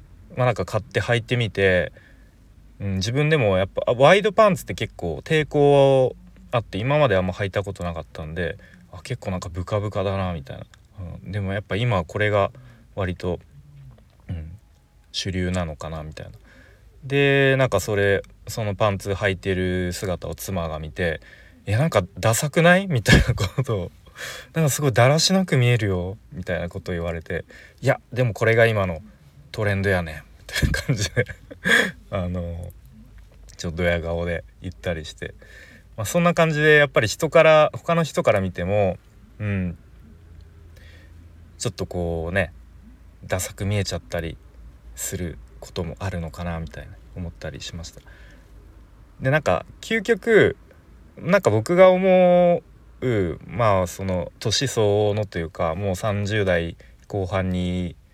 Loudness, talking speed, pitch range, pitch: -22 LUFS, 305 characters per minute, 85-120 Hz, 95 Hz